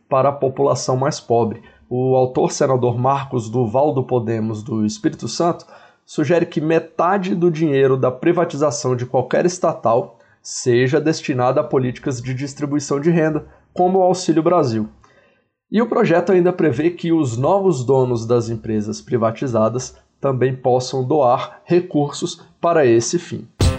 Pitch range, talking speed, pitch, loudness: 125-170 Hz, 140 wpm, 140 Hz, -18 LUFS